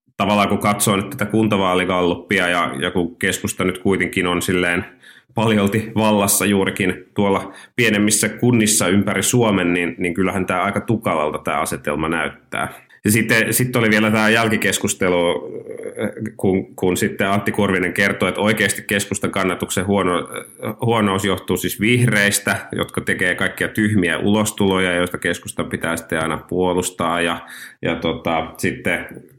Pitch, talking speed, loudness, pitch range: 100 Hz, 140 wpm, -18 LUFS, 90-110 Hz